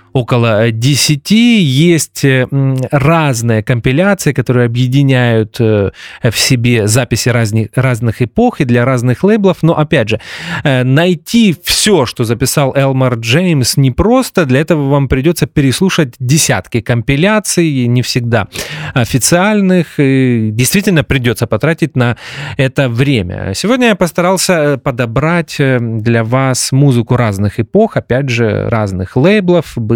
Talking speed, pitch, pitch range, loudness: 115 wpm, 135 Hz, 120-165 Hz, -11 LUFS